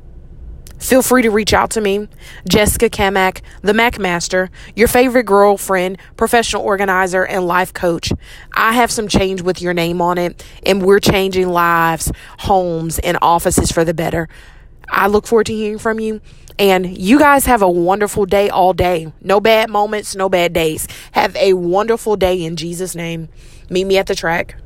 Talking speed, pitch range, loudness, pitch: 175 wpm, 175-210 Hz, -14 LUFS, 190 Hz